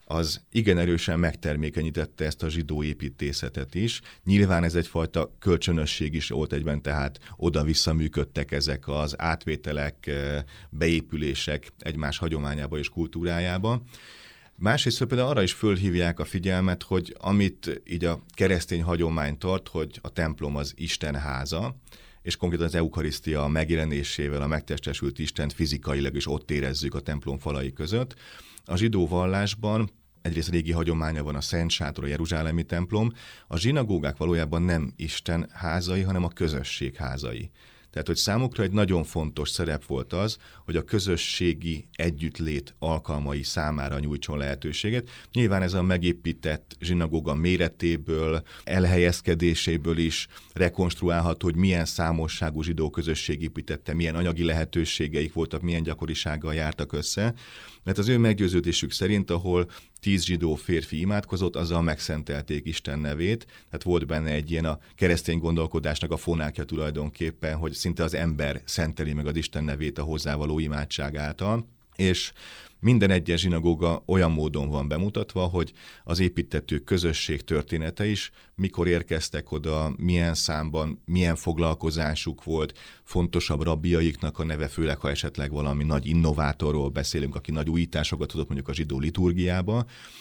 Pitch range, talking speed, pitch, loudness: 75-90 Hz, 135 wpm, 80 Hz, -27 LUFS